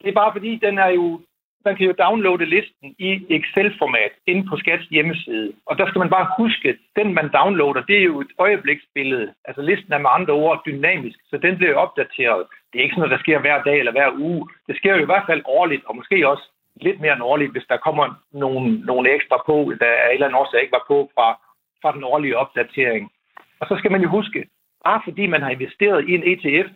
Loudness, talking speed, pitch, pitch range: -18 LUFS, 235 wpm, 180 Hz, 150-200 Hz